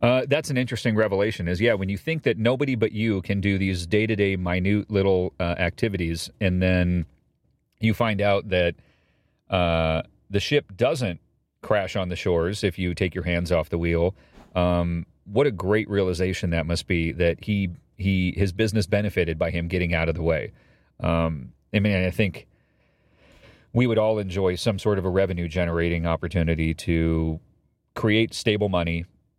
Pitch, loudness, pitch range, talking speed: 95 Hz, -24 LUFS, 85-105 Hz, 170 wpm